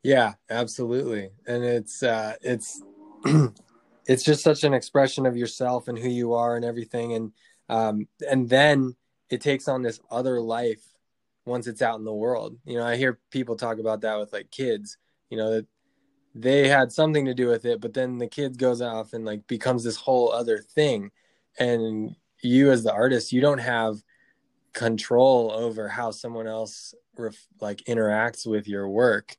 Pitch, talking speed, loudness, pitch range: 120 Hz, 180 wpm, -24 LUFS, 110-130 Hz